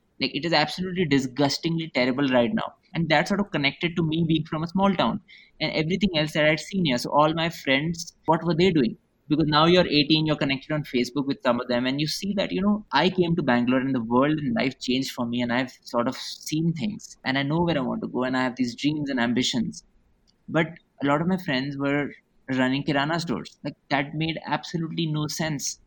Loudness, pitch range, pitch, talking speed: -24 LUFS, 135-170 Hz, 150 Hz, 235 wpm